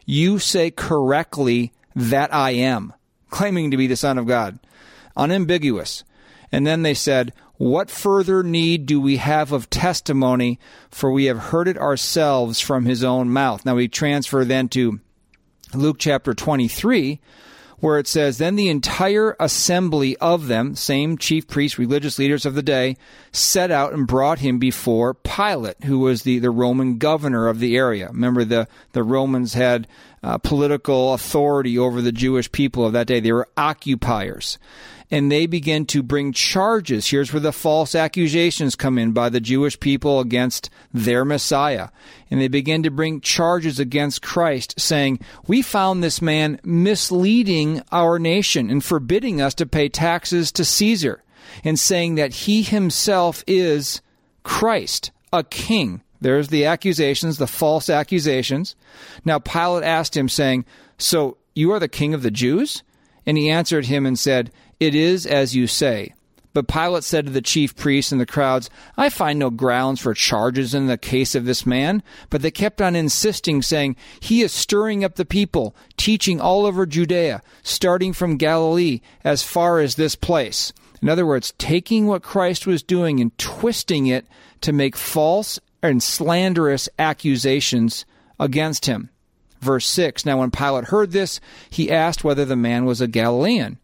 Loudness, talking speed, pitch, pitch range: -19 LUFS, 165 wpm, 145 Hz, 130-170 Hz